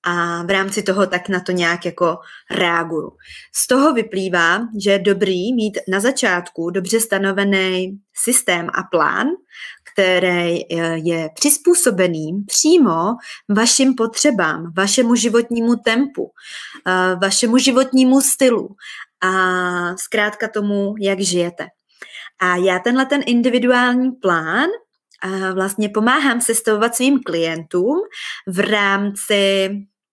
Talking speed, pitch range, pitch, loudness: 110 wpm, 185-240 Hz, 200 Hz, -16 LUFS